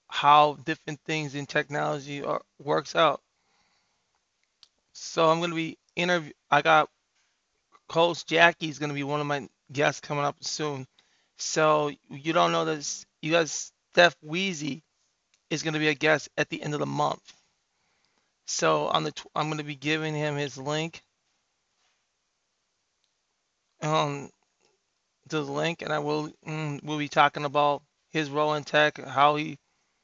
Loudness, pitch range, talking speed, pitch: -26 LUFS, 145-160 Hz, 150 wpm, 150 Hz